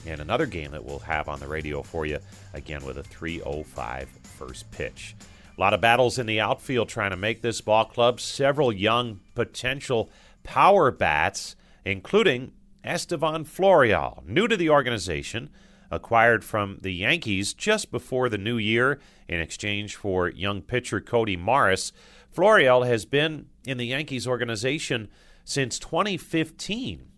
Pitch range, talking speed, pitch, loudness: 95-130 Hz, 150 wpm, 115 Hz, -24 LUFS